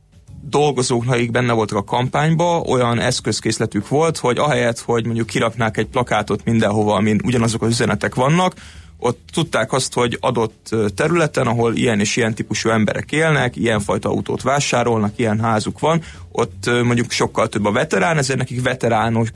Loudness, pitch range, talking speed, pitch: -18 LUFS, 110-130 Hz, 160 wpm, 120 Hz